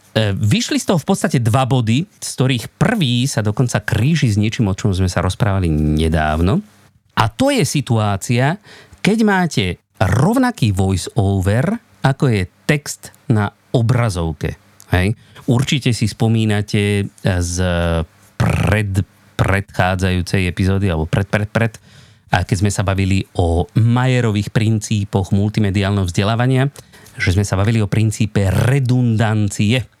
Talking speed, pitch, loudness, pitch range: 130 wpm, 110 Hz, -17 LUFS, 100-125 Hz